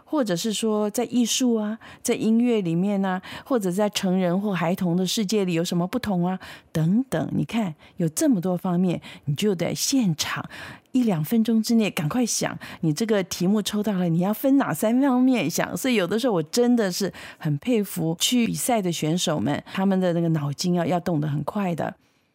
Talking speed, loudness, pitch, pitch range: 290 characters per minute, -23 LUFS, 200 Hz, 175-230 Hz